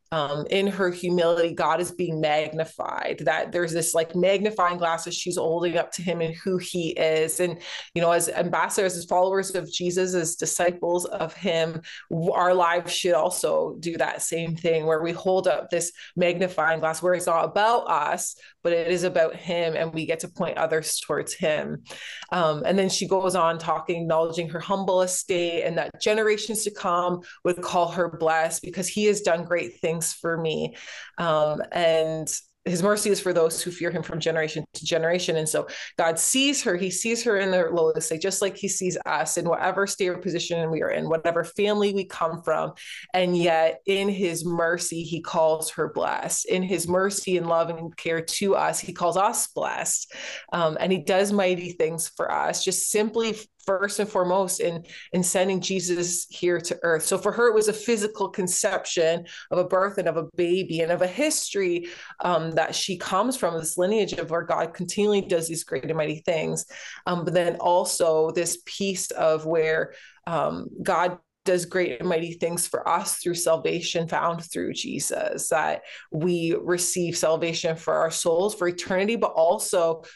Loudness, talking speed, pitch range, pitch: -24 LUFS, 190 wpm, 165-185 Hz, 175 Hz